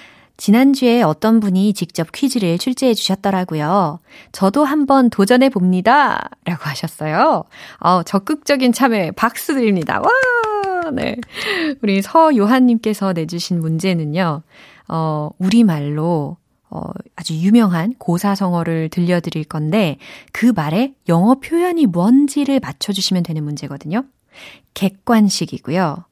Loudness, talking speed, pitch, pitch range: -16 LUFS, 275 characters per minute, 195 Hz, 170-250 Hz